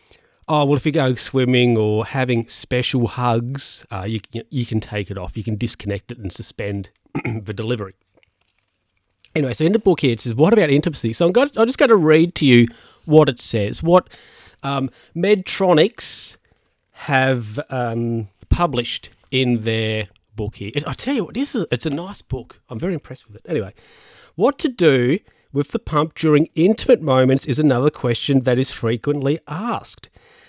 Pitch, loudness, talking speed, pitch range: 130 Hz, -19 LUFS, 185 wpm, 115-155 Hz